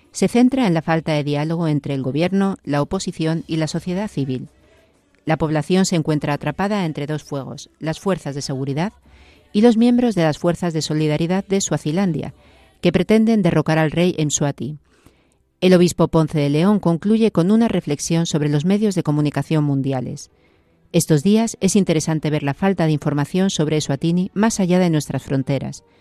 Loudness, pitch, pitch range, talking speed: -19 LUFS, 160 Hz, 145-185 Hz, 175 wpm